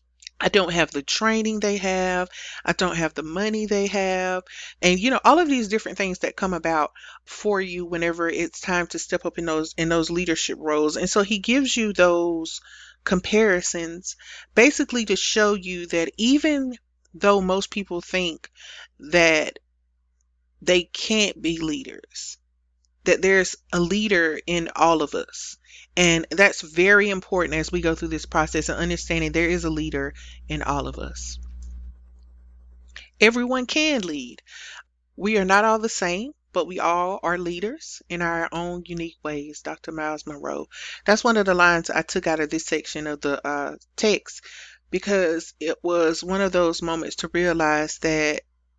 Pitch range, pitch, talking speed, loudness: 155-200 Hz, 175 Hz, 165 wpm, -22 LUFS